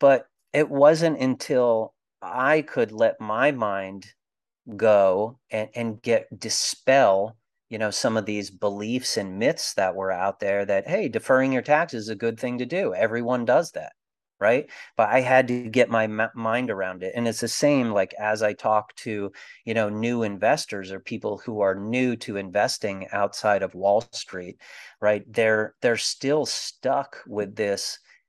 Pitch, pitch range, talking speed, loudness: 110 Hz, 100-125 Hz, 175 wpm, -24 LUFS